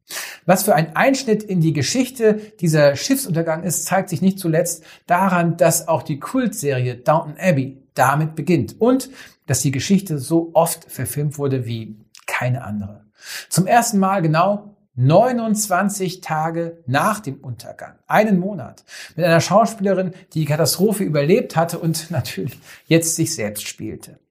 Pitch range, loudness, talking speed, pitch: 145-190 Hz, -19 LUFS, 145 wpm, 165 Hz